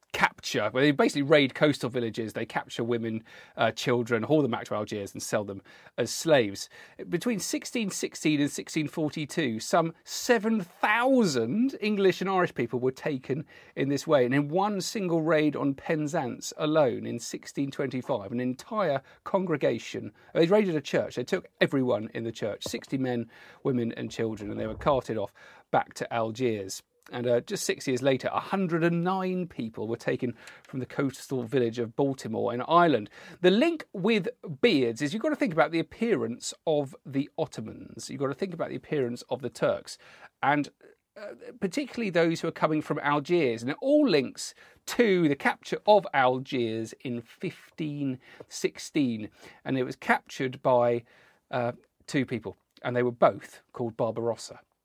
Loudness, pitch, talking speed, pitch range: -28 LUFS, 140 Hz, 165 wpm, 120-175 Hz